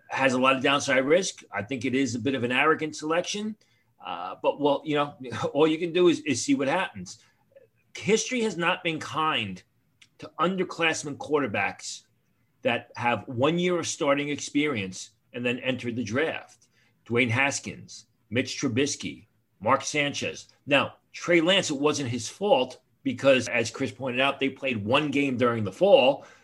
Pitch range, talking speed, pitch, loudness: 125-170 Hz, 170 wpm, 140 Hz, -26 LUFS